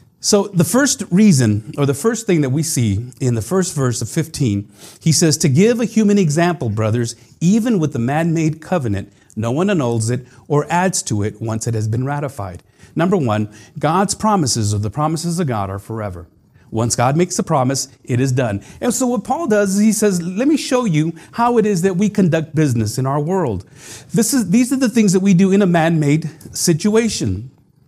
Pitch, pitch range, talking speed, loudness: 155 Hz, 120-195 Hz, 210 wpm, -17 LUFS